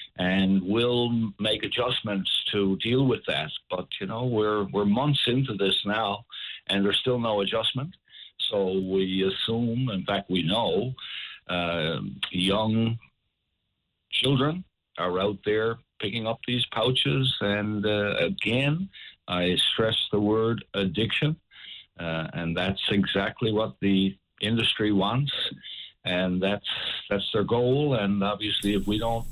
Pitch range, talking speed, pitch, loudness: 95-120 Hz, 135 wpm, 105 Hz, -26 LUFS